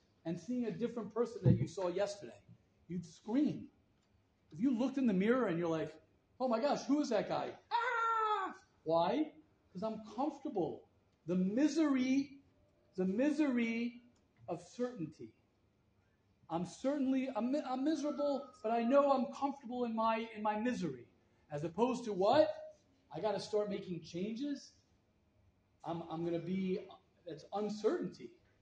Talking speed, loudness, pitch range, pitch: 145 wpm, -37 LUFS, 170-275 Hz, 220 Hz